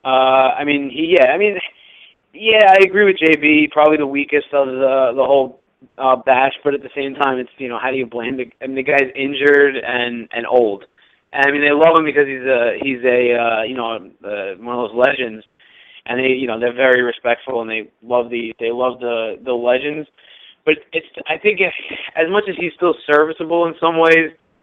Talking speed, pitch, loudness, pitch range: 220 wpm, 135 Hz, -16 LUFS, 125-155 Hz